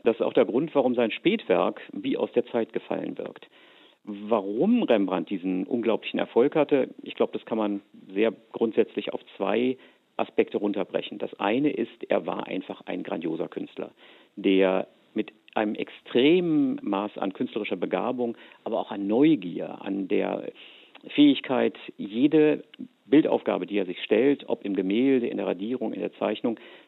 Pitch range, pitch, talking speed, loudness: 100-145 Hz, 115 Hz, 155 wpm, -26 LUFS